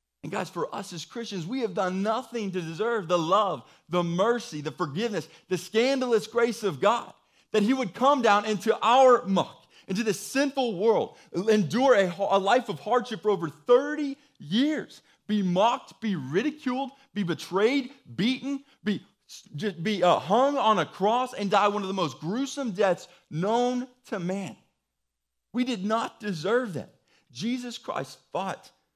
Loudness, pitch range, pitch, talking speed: -27 LUFS, 185-245 Hz, 210 Hz, 160 wpm